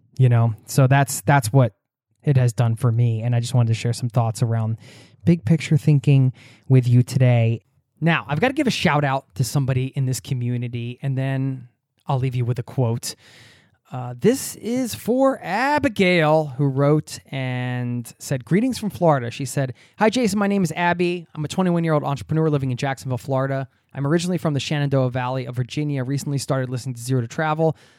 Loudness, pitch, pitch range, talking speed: -21 LUFS, 135 Hz, 125-155 Hz, 195 wpm